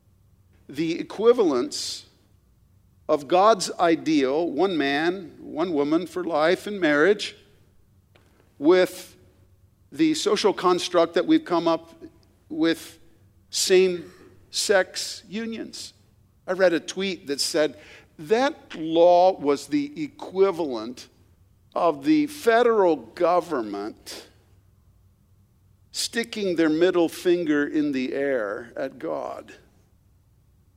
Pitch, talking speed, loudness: 165 Hz, 95 wpm, -23 LUFS